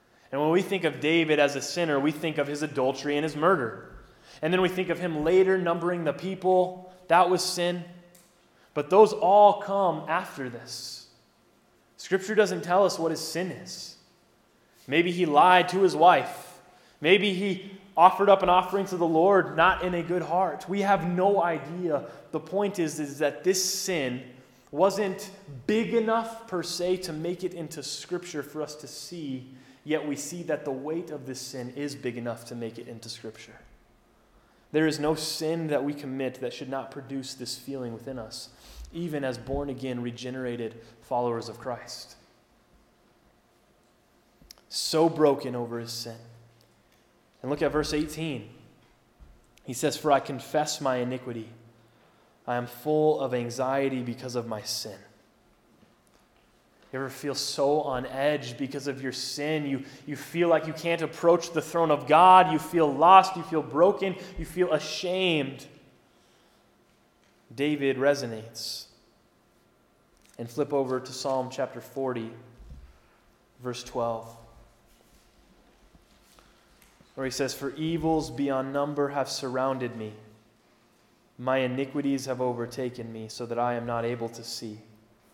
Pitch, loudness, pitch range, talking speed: 145 Hz, -26 LUFS, 125-175 Hz, 155 wpm